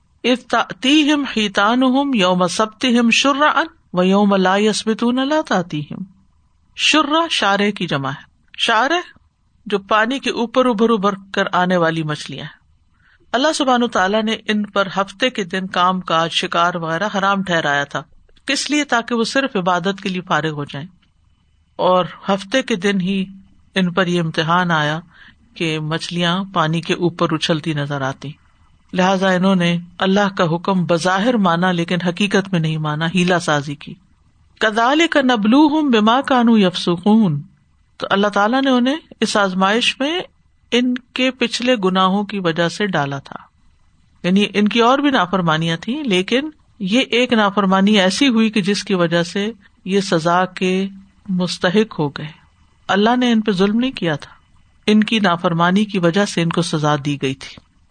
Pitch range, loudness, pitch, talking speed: 170-230 Hz, -17 LUFS, 195 Hz, 160 wpm